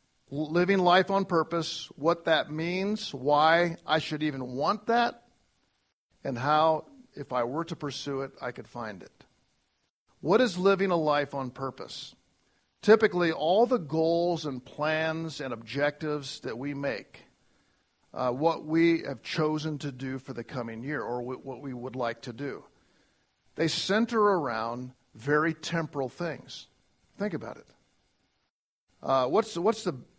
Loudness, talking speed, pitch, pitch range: -28 LUFS, 145 wpm, 150 Hz, 130-170 Hz